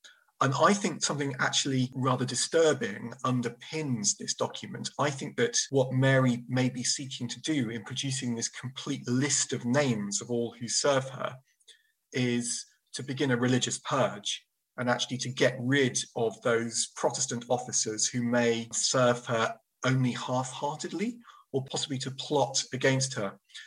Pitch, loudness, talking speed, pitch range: 130 Hz, -29 LUFS, 150 wpm, 120-135 Hz